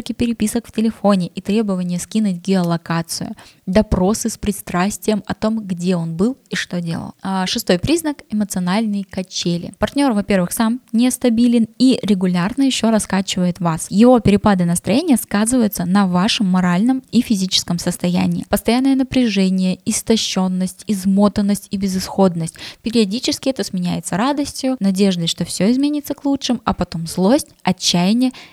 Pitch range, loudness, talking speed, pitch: 185-235 Hz, -17 LUFS, 130 wpm, 205 Hz